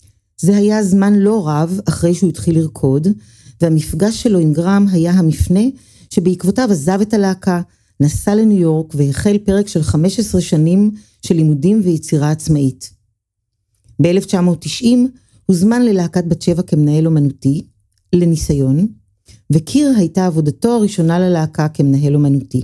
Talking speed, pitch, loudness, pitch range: 120 wpm, 170 Hz, -14 LUFS, 145-200 Hz